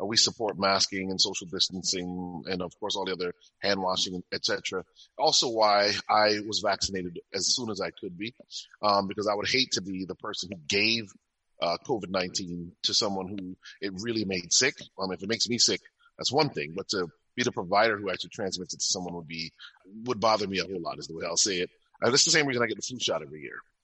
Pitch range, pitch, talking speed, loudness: 95-105 Hz, 95 Hz, 230 wpm, -27 LUFS